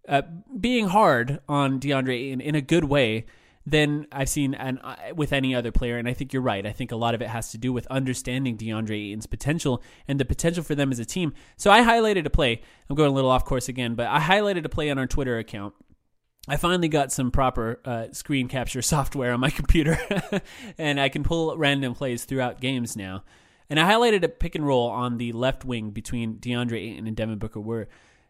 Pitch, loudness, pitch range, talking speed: 130 Hz, -24 LUFS, 120-150 Hz, 225 wpm